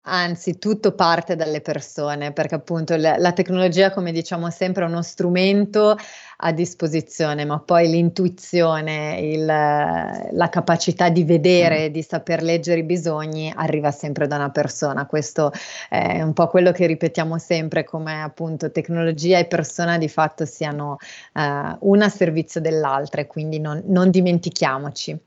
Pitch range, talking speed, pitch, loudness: 155-175 Hz, 145 wpm, 165 Hz, -20 LUFS